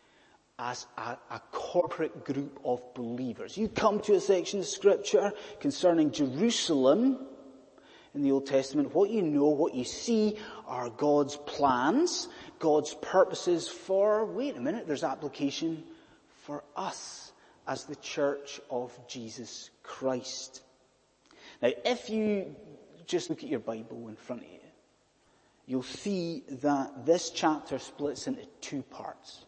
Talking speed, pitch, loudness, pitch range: 135 wpm, 150 Hz, -30 LUFS, 130-210 Hz